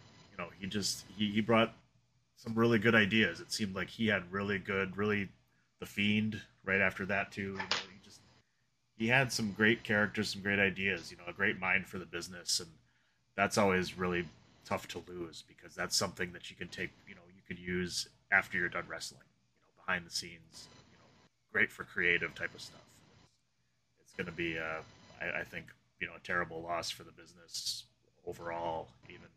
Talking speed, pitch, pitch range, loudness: 205 wpm, 100 Hz, 90-110 Hz, -34 LUFS